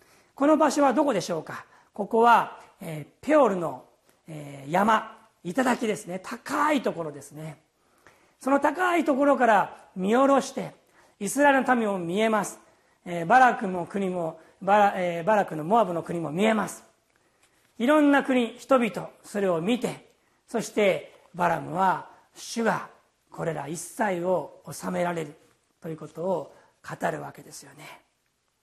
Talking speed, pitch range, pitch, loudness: 280 characters per minute, 170-255 Hz, 210 Hz, -25 LUFS